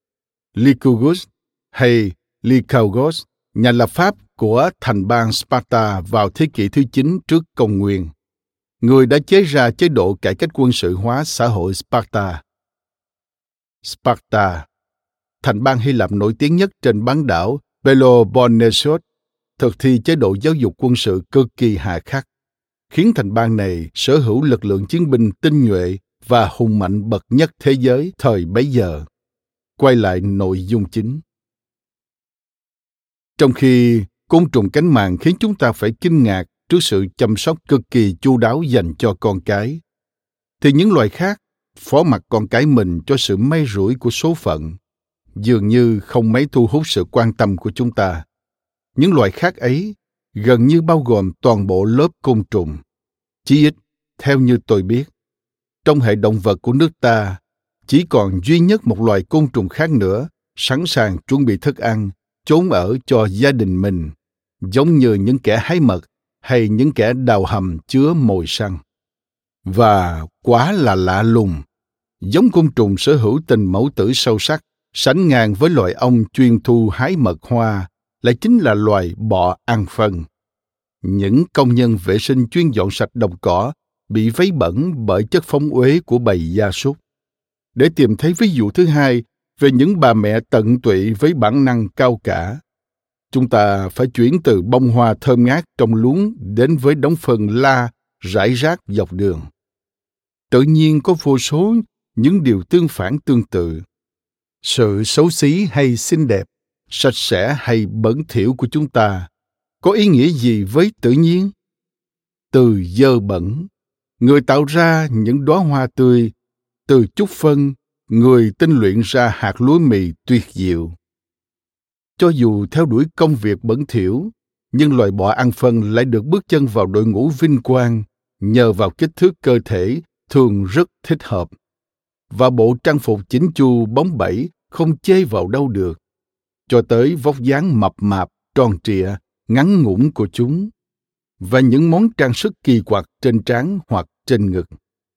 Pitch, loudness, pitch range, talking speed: 120 Hz, -15 LUFS, 105-145 Hz, 170 wpm